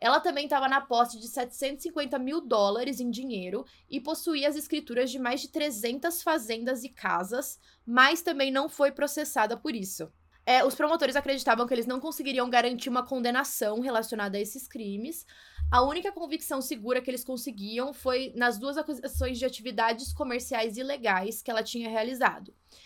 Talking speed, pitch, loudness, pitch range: 165 wpm, 255 Hz, -29 LUFS, 235-285 Hz